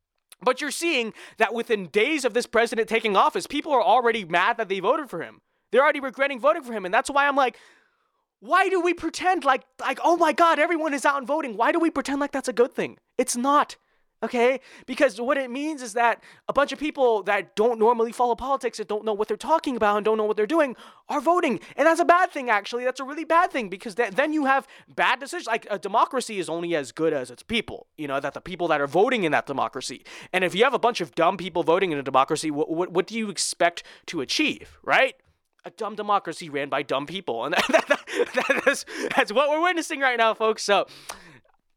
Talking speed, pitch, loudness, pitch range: 245 wpm, 245 Hz, -23 LUFS, 210-295 Hz